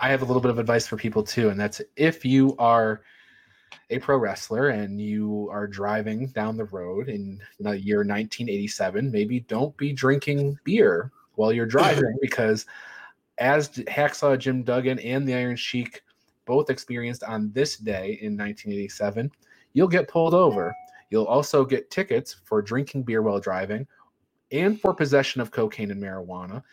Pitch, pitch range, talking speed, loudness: 120 Hz, 105-135 Hz, 165 wpm, -24 LUFS